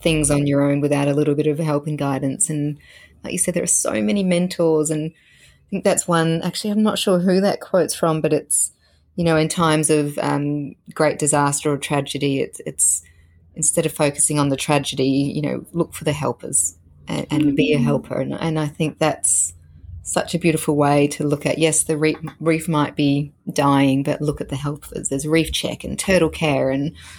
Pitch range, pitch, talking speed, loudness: 140-160 Hz, 150 Hz, 210 wpm, -19 LUFS